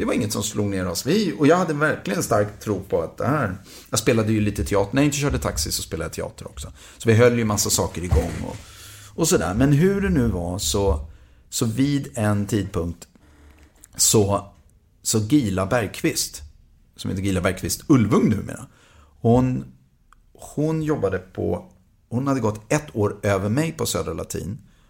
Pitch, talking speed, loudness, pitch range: 105 Hz, 190 wpm, -22 LUFS, 90-120 Hz